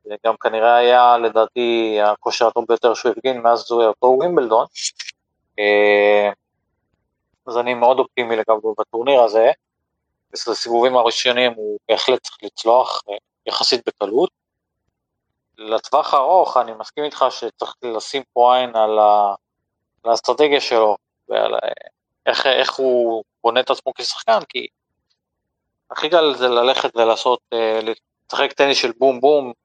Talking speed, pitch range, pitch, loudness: 125 wpm, 110-125 Hz, 115 Hz, -17 LUFS